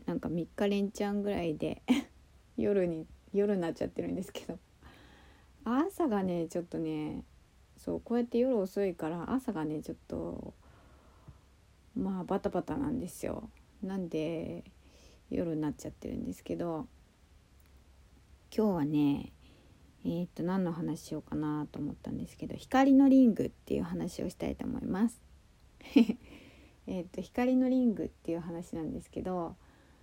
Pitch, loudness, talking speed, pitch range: 175 Hz, -33 LUFS, 285 characters per minute, 150-225 Hz